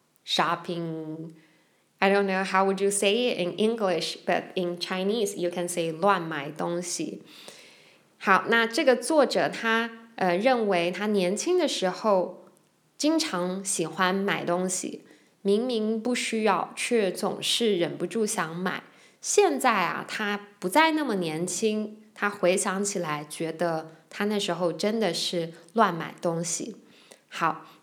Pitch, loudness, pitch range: 190 Hz, -26 LUFS, 175-220 Hz